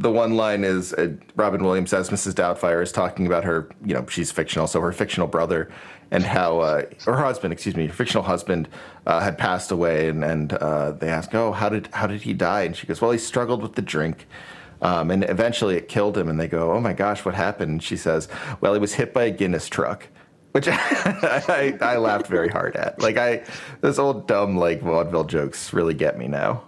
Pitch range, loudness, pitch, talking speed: 85-110 Hz, -22 LUFS, 95 Hz, 225 wpm